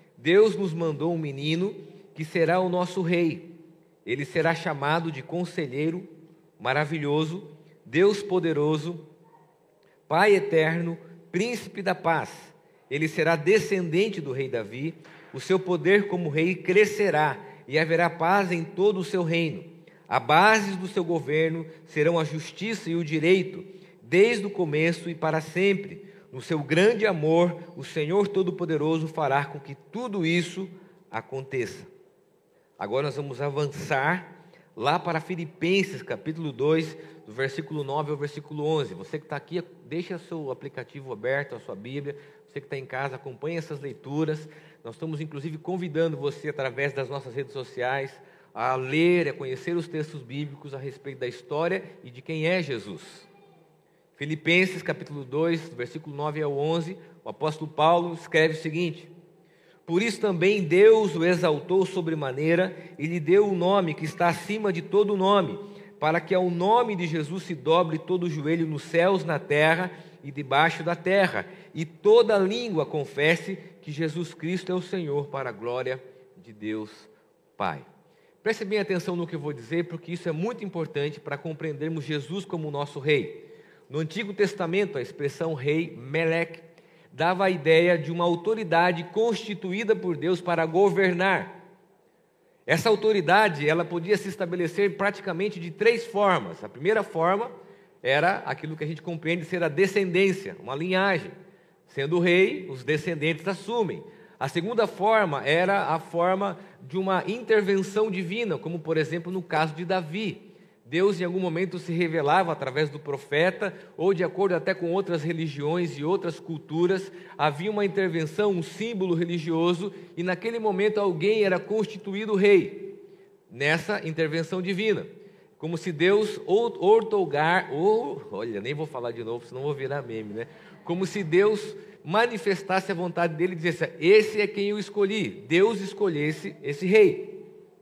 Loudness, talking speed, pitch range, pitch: -26 LUFS, 155 wpm, 155-195 Hz, 175 Hz